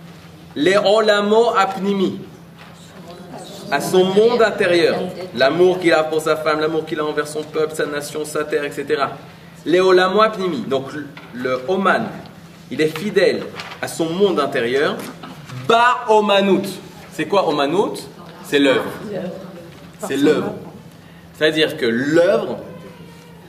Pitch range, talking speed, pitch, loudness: 155-195 Hz, 120 wpm, 175 Hz, -17 LUFS